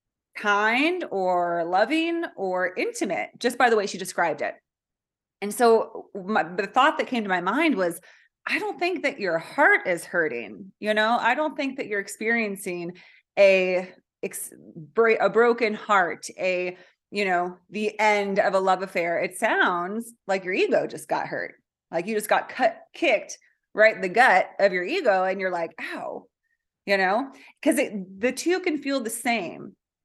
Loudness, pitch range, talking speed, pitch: -24 LUFS, 185-275 Hz, 170 wpm, 210 Hz